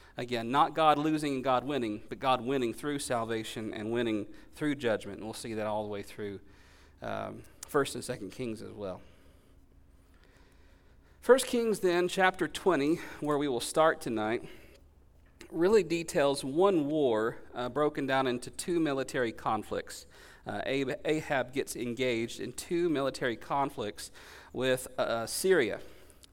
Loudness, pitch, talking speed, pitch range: -31 LUFS, 125 Hz, 145 wpm, 105-150 Hz